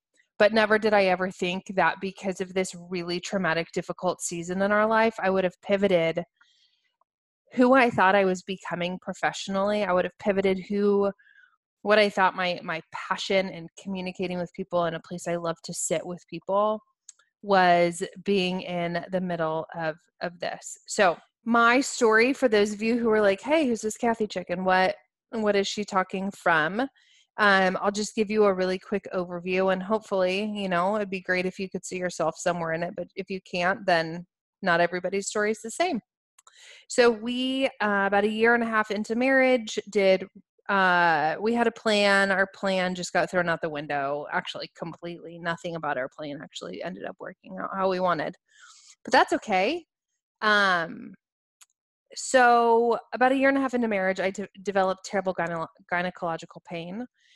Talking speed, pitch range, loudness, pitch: 185 wpm, 175-215 Hz, -25 LUFS, 195 Hz